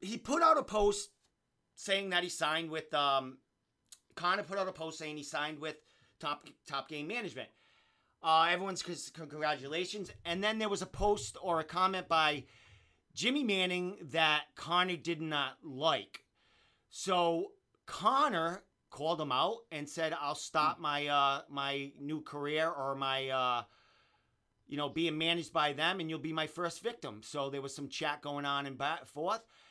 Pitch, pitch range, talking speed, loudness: 160 Hz, 145-180 Hz, 170 wpm, -34 LUFS